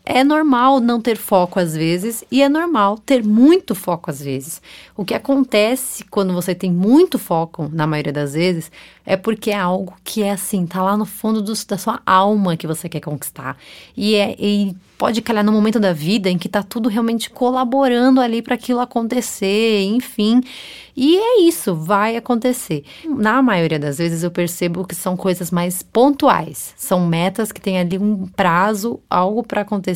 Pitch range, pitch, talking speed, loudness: 180-245 Hz, 205 Hz, 185 wpm, -17 LUFS